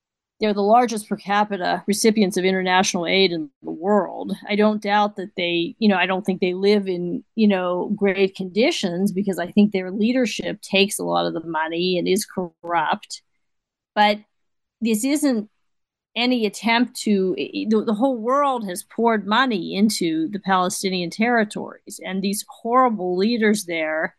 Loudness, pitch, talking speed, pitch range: -21 LUFS, 200 Hz, 160 wpm, 185-220 Hz